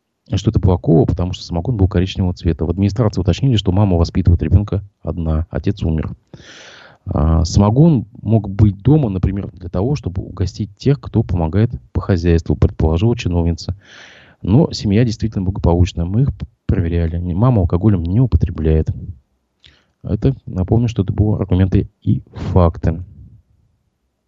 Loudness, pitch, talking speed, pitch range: -17 LUFS, 95 Hz, 135 wpm, 85-110 Hz